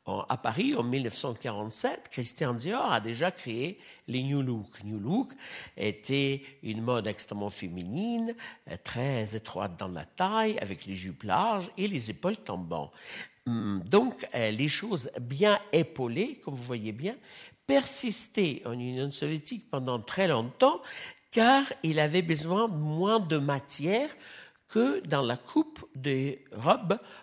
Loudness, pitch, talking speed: -30 LUFS, 140 Hz, 135 wpm